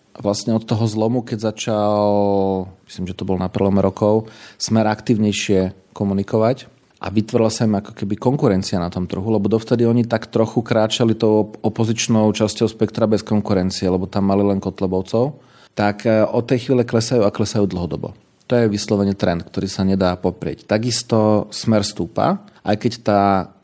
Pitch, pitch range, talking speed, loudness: 105 Hz, 100-115 Hz, 165 wpm, -19 LUFS